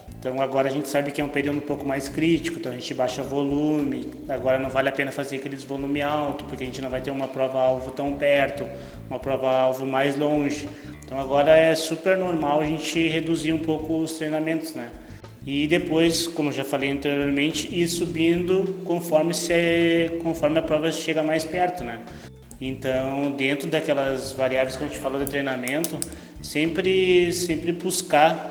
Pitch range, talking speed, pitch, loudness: 135-160 Hz, 185 wpm, 145 Hz, -24 LUFS